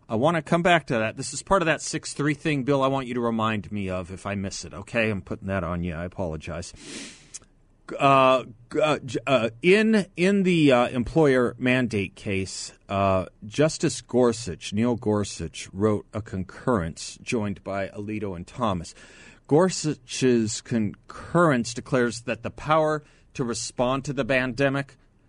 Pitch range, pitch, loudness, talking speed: 100-140 Hz, 120 Hz, -25 LUFS, 160 wpm